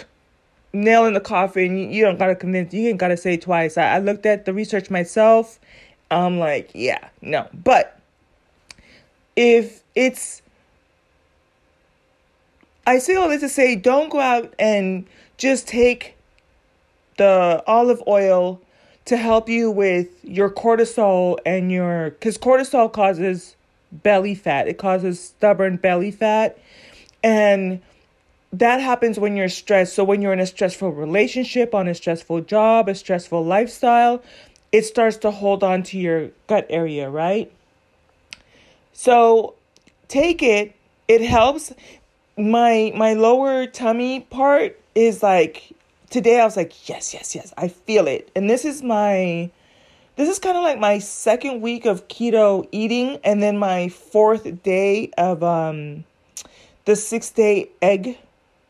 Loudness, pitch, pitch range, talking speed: -18 LUFS, 210 Hz, 185-235 Hz, 140 wpm